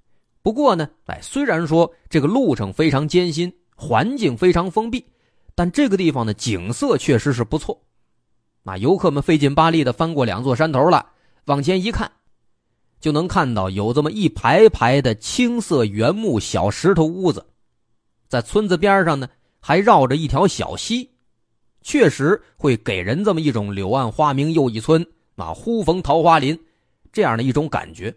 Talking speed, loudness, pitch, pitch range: 245 characters per minute, -18 LUFS, 150 Hz, 120-170 Hz